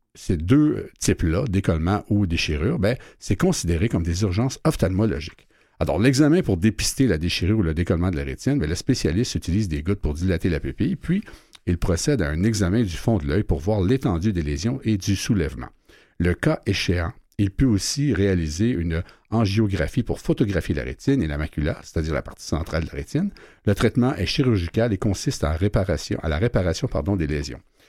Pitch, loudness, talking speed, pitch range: 95 Hz, -23 LUFS, 195 wpm, 85-115 Hz